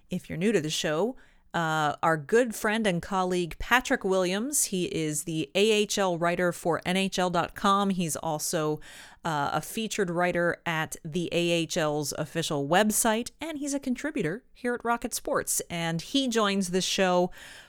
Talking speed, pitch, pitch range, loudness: 155 wpm, 180 Hz, 165-215 Hz, -27 LUFS